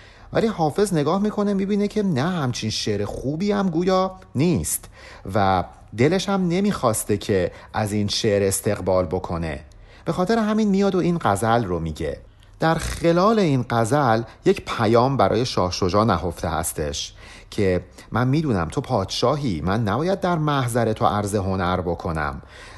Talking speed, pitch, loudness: 150 wpm, 115 Hz, -22 LUFS